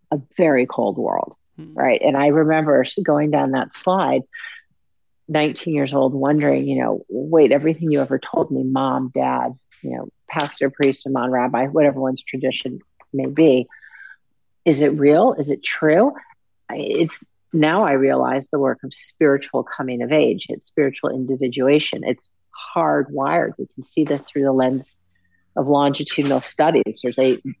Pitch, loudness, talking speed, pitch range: 140 Hz, -19 LUFS, 155 wpm, 130-150 Hz